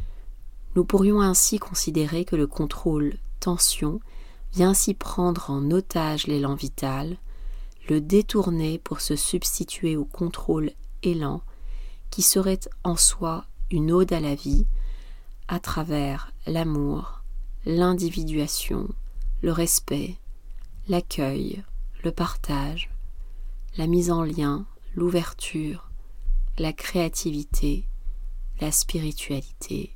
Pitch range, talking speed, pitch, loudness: 135-175 Hz, 100 wpm, 155 Hz, -25 LUFS